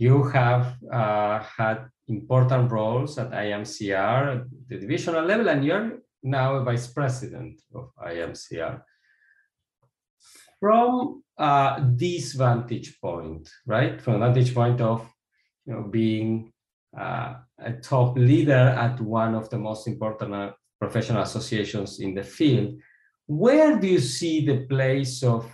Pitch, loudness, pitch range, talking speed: 125 Hz, -24 LUFS, 110-135 Hz, 130 wpm